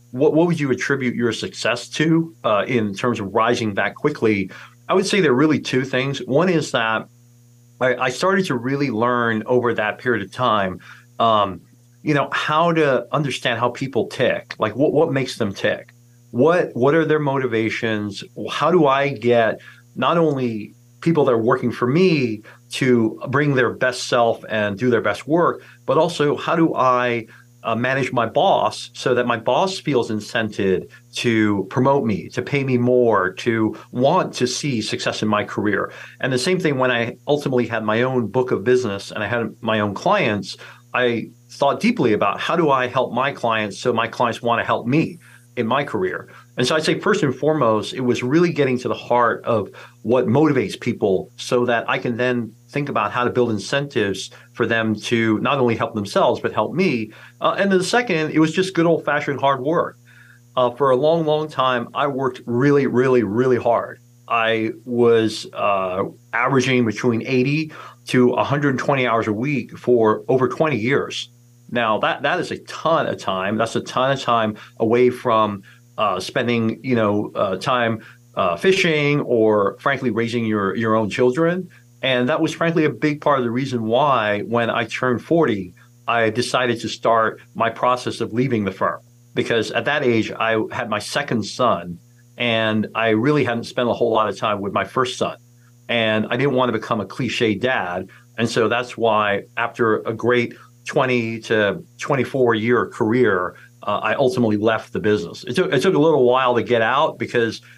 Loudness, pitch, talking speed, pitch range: -20 LUFS, 120 Hz, 190 wpm, 115-135 Hz